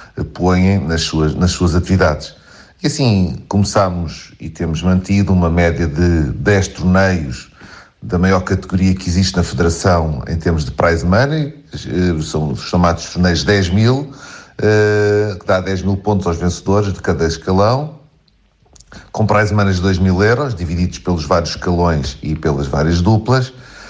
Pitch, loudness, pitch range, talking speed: 95 Hz, -15 LUFS, 85-105 Hz, 155 wpm